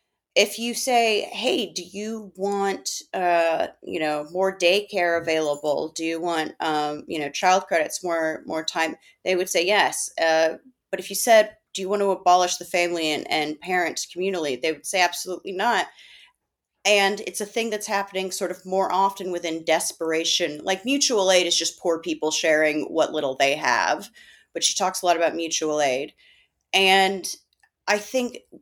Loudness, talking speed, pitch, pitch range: -23 LUFS, 175 wpm, 180 Hz, 160-195 Hz